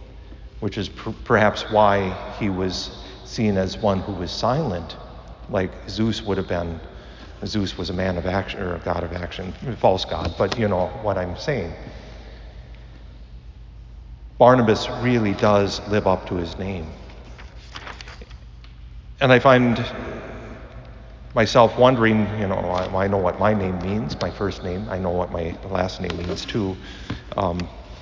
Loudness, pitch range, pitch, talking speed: -22 LUFS, 85-105 Hz, 95 Hz, 155 wpm